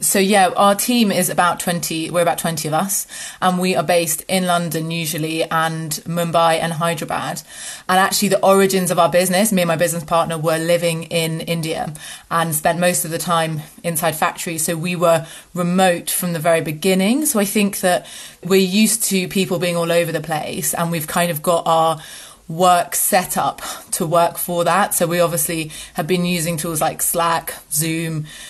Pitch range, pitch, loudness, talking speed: 165-185 Hz, 170 Hz, -18 LUFS, 190 wpm